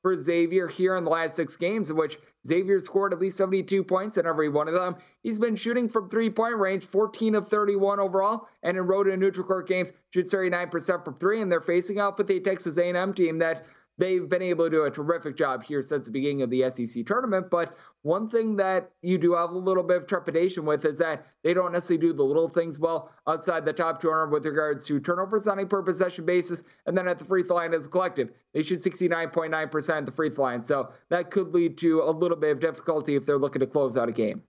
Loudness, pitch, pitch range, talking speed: -26 LUFS, 175 Hz, 160-190 Hz, 245 wpm